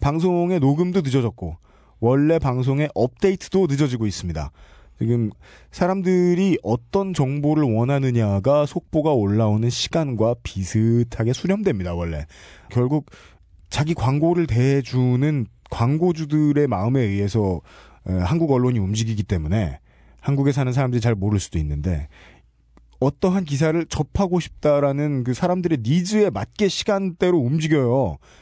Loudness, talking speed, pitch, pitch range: -21 LUFS, 310 characters per minute, 130 Hz, 100-155 Hz